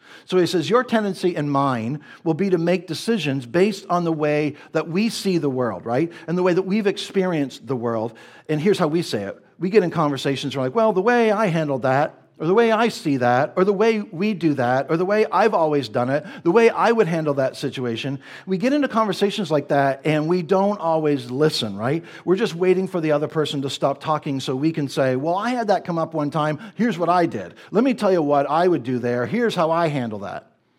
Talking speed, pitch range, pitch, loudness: 245 wpm, 140-195 Hz, 165 Hz, -21 LUFS